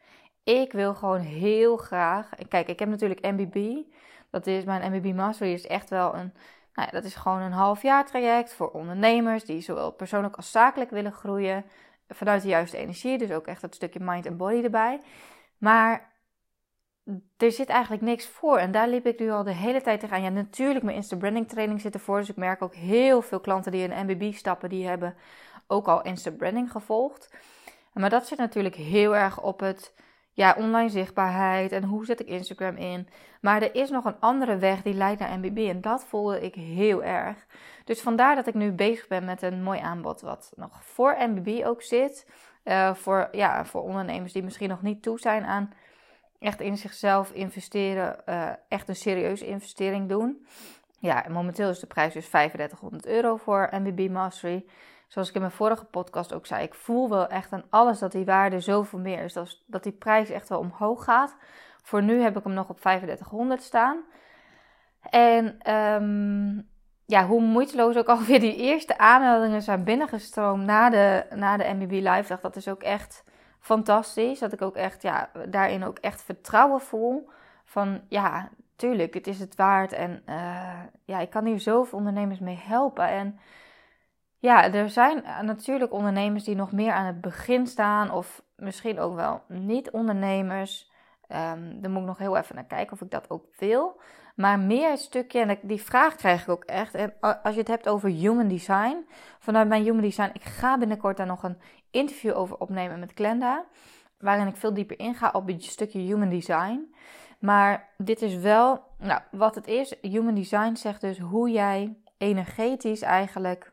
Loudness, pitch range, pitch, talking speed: -25 LUFS, 190-230 Hz, 205 Hz, 185 wpm